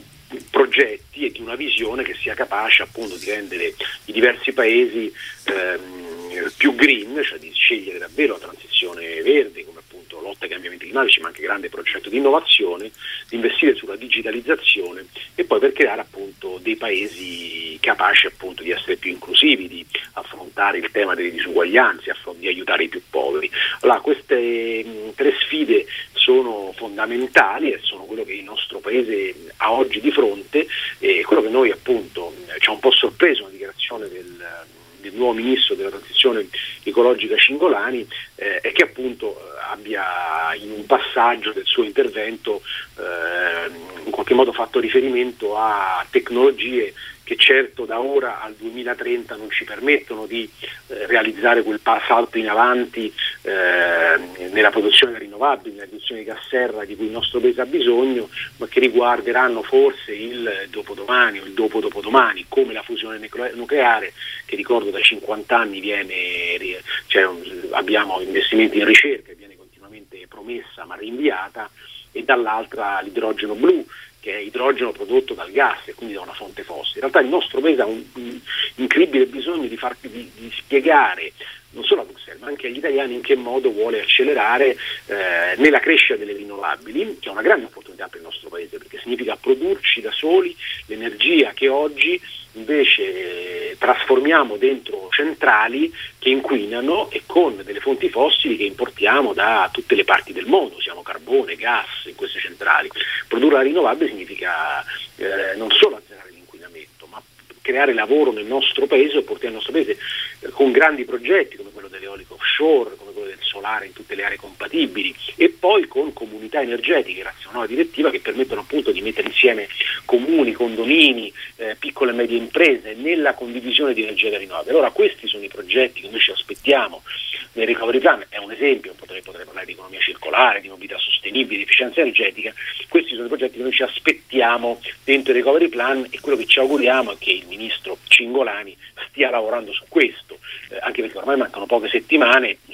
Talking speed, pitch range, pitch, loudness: 165 wpm, 360-420 Hz, 395 Hz, -18 LUFS